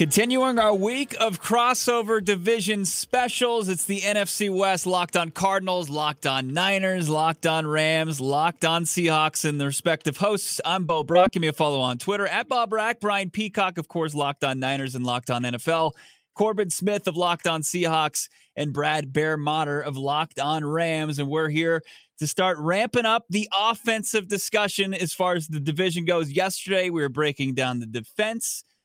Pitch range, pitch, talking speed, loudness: 155-205 Hz, 175 Hz, 180 wpm, -24 LUFS